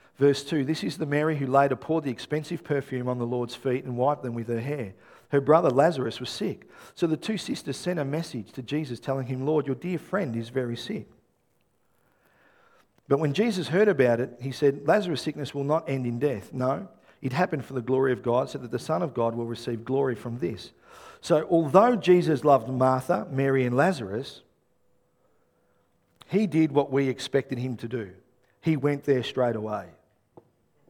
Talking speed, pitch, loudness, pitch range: 195 wpm, 135 Hz, -26 LUFS, 125-155 Hz